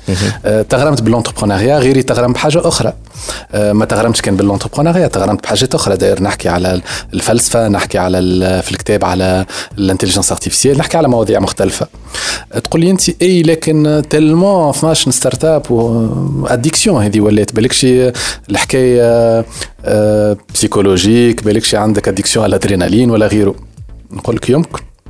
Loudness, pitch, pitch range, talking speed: -11 LUFS, 115 Hz, 100-135 Hz, 135 wpm